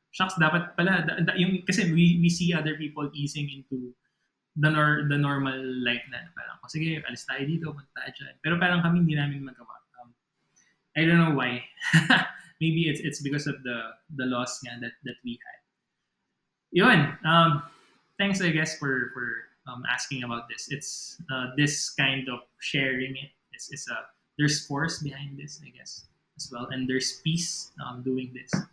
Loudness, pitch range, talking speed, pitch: -26 LUFS, 130-165 Hz, 165 wpm, 150 Hz